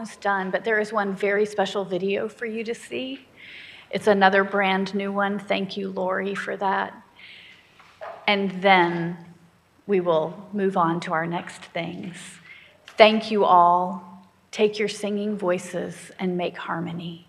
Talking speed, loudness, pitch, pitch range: 145 wpm, -23 LUFS, 195 Hz, 175-205 Hz